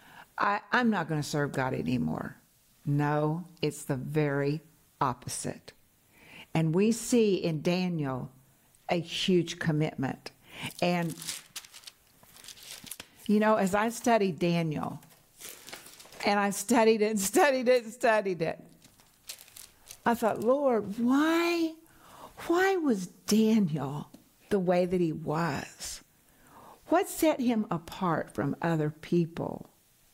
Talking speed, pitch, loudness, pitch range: 115 wpm, 185 Hz, -29 LUFS, 155-225 Hz